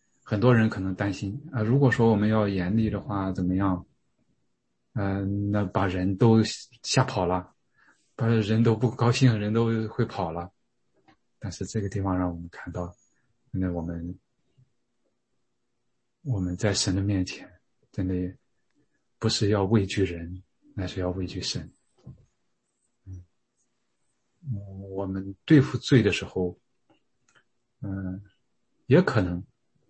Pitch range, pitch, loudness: 90-115 Hz, 100 Hz, -26 LUFS